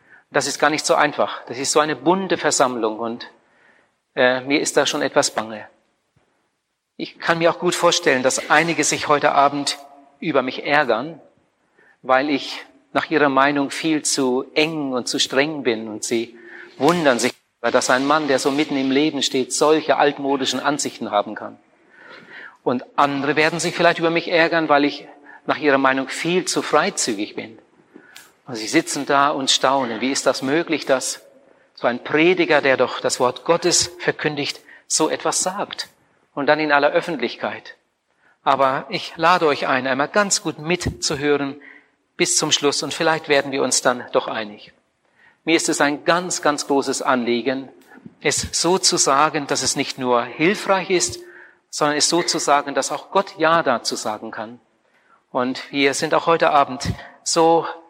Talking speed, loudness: 170 wpm, -19 LUFS